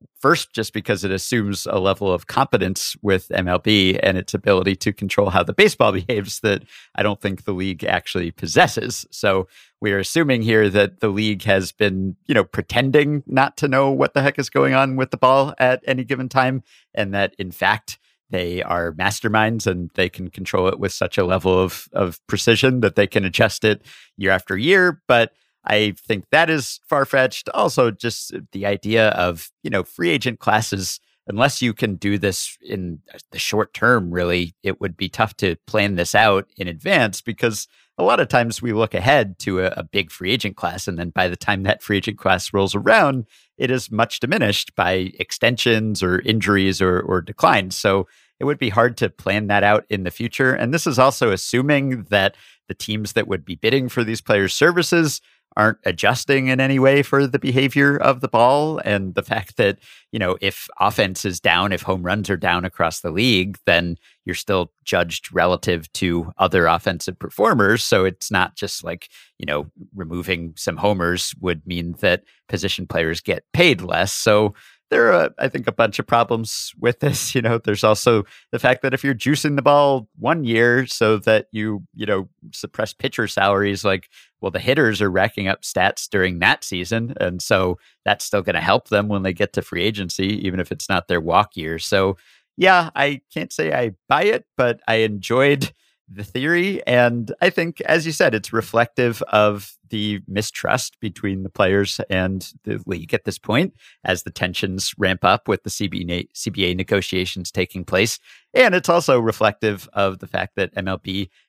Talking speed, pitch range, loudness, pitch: 195 wpm, 95-125 Hz, -19 LUFS, 105 Hz